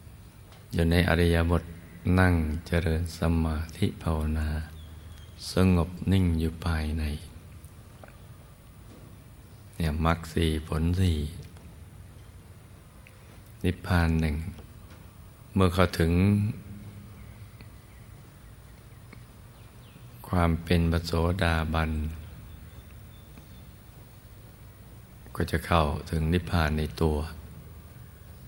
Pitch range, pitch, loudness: 80-105 Hz, 90 Hz, -27 LUFS